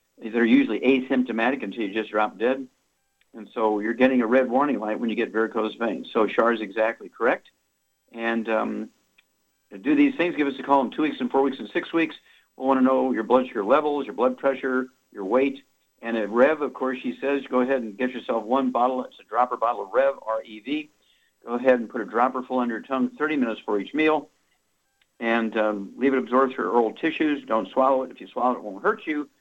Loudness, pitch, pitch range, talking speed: -24 LUFS, 125 Hz, 115-135 Hz, 235 wpm